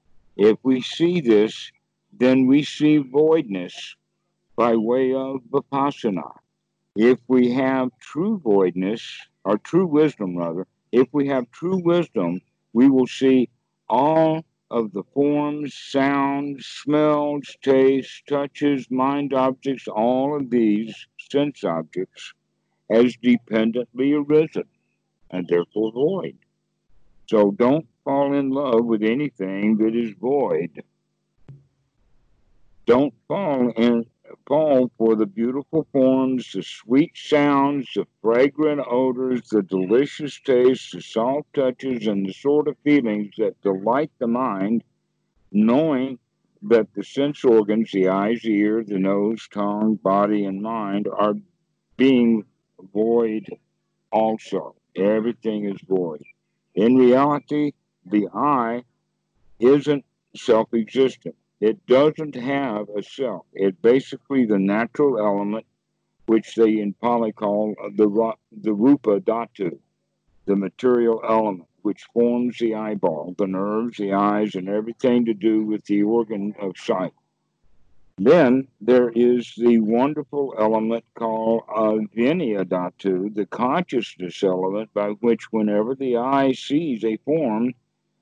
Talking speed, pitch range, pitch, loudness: 120 wpm, 105-135 Hz, 115 Hz, -21 LUFS